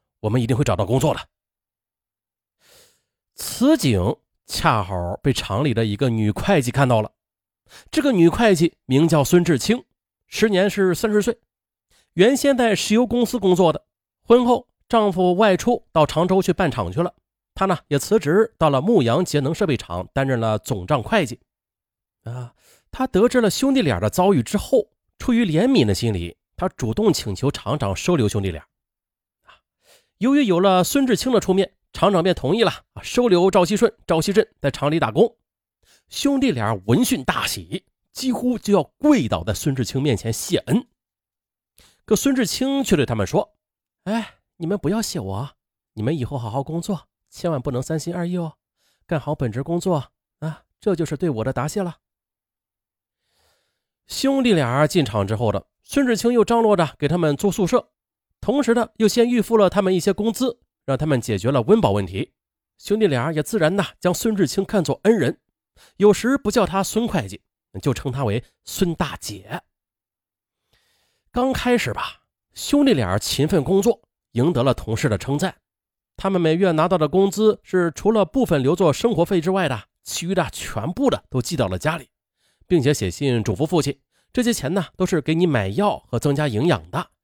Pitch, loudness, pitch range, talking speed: 170 Hz, -20 LUFS, 125-210 Hz, 255 characters per minute